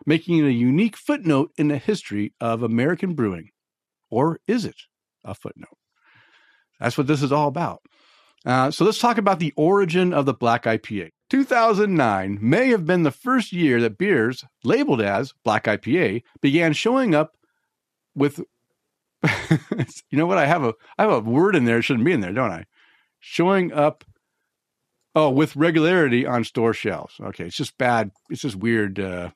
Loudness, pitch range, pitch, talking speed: -21 LUFS, 115-175 Hz, 145 Hz, 180 wpm